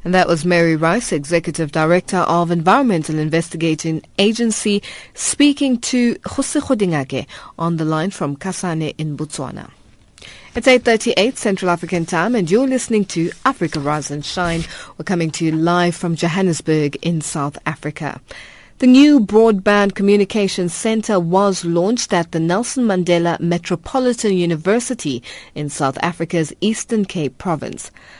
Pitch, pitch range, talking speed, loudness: 175 Hz, 160-210 Hz, 135 wpm, -17 LUFS